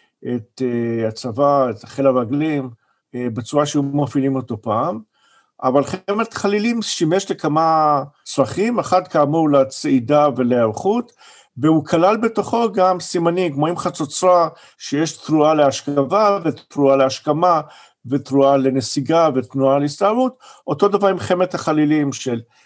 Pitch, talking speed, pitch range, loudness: 150 Hz, 110 wpm, 135-180 Hz, -18 LUFS